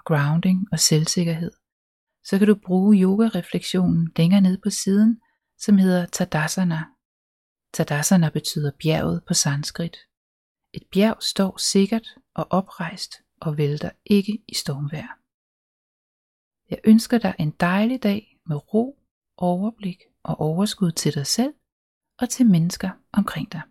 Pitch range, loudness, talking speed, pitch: 160-210 Hz, -21 LUFS, 125 wpm, 185 Hz